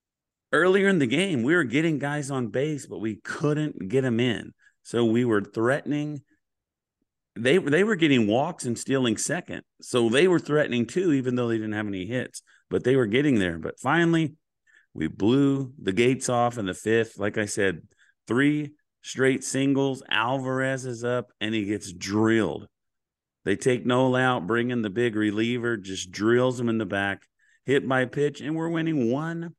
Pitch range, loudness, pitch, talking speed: 110-140 Hz, -25 LUFS, 125 Hz, 185 wpm